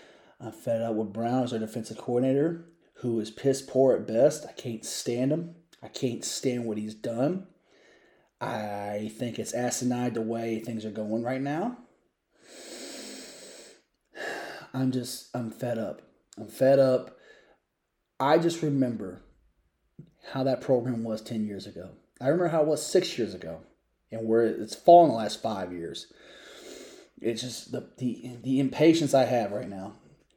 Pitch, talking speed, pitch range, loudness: 120 Hz, 160 wpm, 110-135 Hz, -28 LUFS